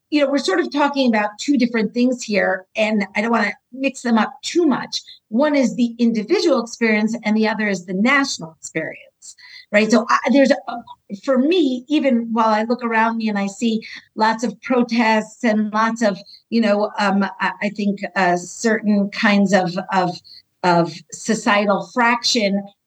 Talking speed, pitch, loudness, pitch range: 180 wpm, 220 Hz, -18 LUFS, 200-245 Hz